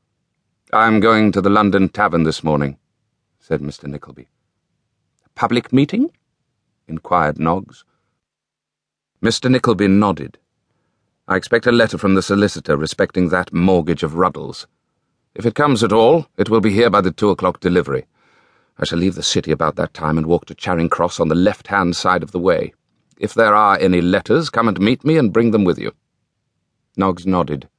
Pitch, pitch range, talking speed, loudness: 95 Hz, 85-115 Hz, 175 wpm, -16 LUFS